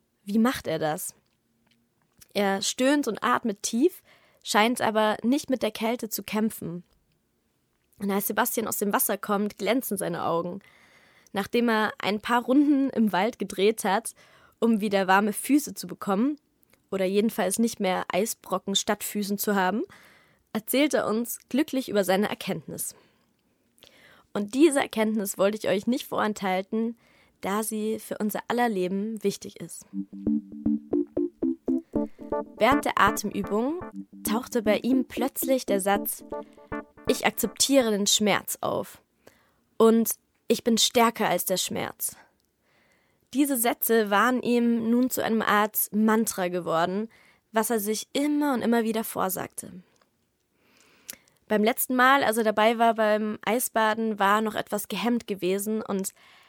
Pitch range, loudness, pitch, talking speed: 195-235 Hz, -25 LUFS, 215 Hz, 135 wpm